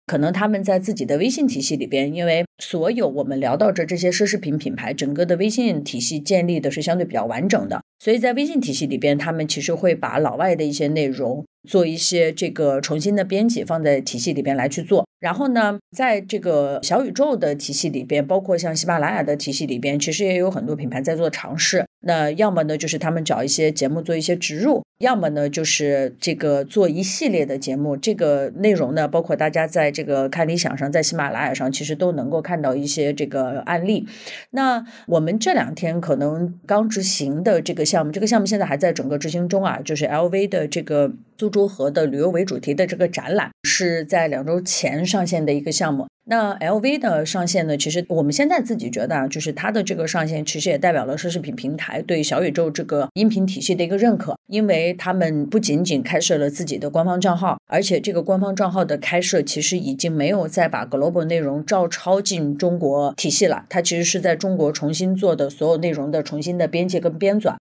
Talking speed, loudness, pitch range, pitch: 340 characters per minute, -20 LUFS, 150-190 Hz, 170 Hz